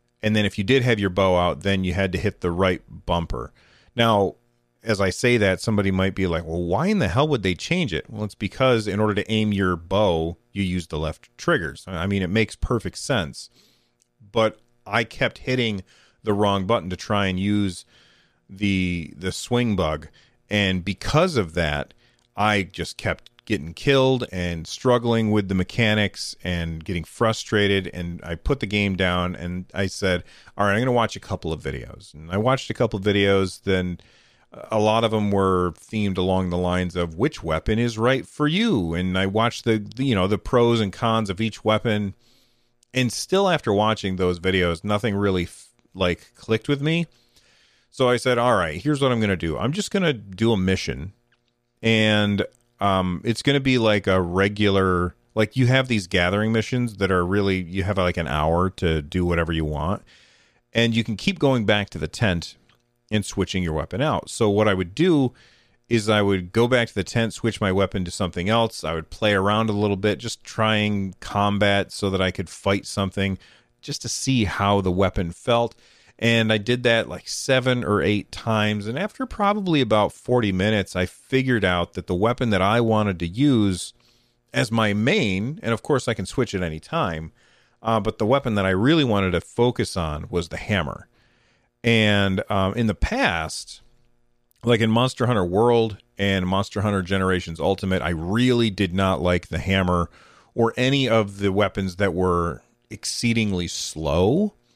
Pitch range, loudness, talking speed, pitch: 90-115 Hz, -22 LUFS, 195 wpm, 100 Hz